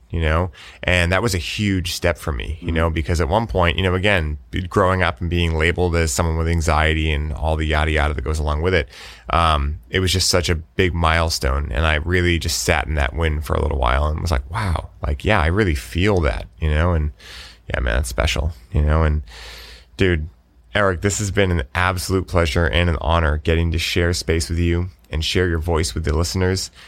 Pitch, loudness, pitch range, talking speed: 85 Hz, -20 LUFS, 80-90 Hz, 230 wpm